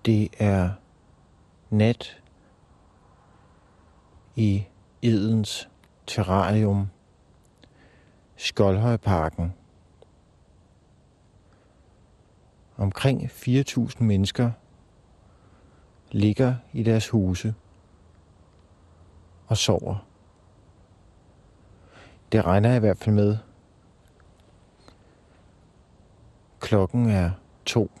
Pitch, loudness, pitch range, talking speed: 95 Hz, -24 LUFS, 90-110 Hz, 55 wpm